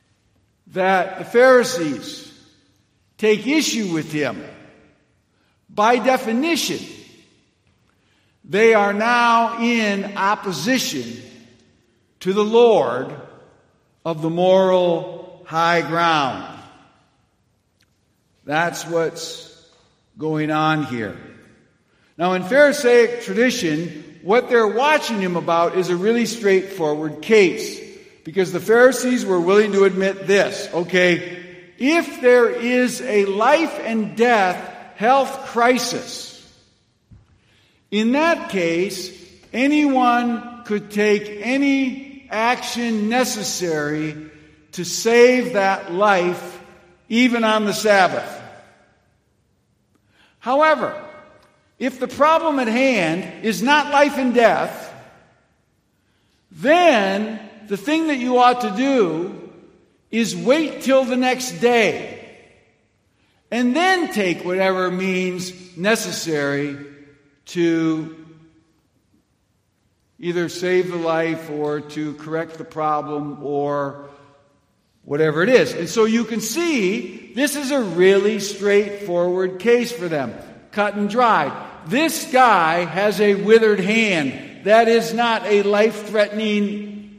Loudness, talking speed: -18 LUFS, 105 wpm